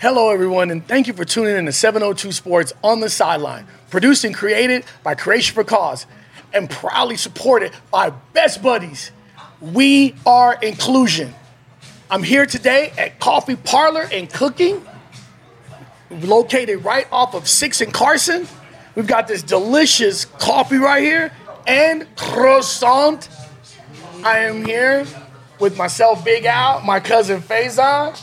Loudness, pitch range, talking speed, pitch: -15 LUFS, 190-265 Hz, 135 wpm, 230 Hz